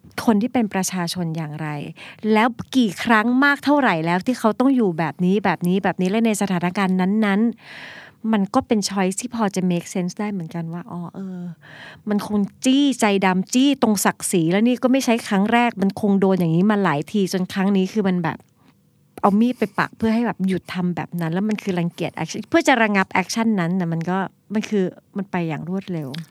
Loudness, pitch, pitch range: -20 LUFS, 195 Hz, 180-220 Hz